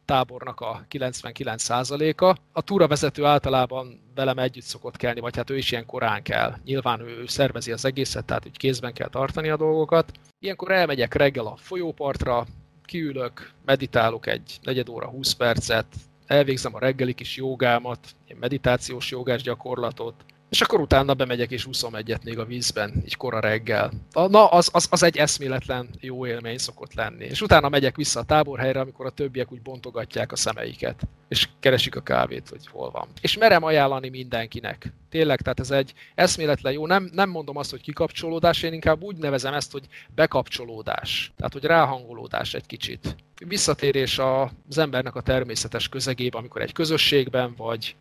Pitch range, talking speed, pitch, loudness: 120-150 Hz, 165 wpm, 130 Hz, -23 LUFS